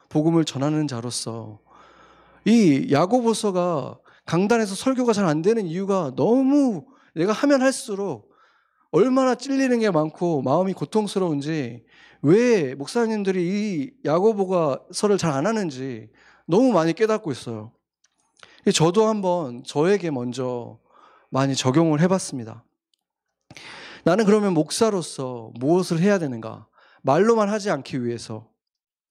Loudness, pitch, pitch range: -22 LUFS, 175 Hz, 135-215 Hz